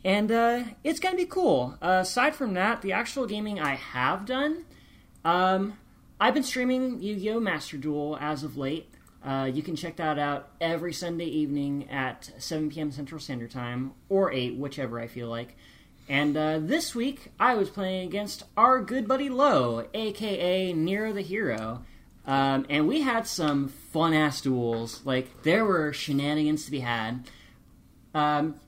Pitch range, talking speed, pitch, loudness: 135-205 Hz, 165 wpm, 155 Hz, -28 LUFS